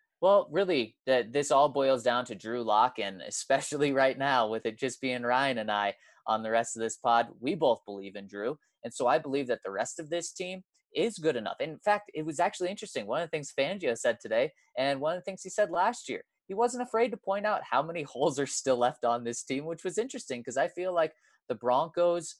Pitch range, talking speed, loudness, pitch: 120-185 Hz, 245 wpm, -30 LUFS, 145 Hz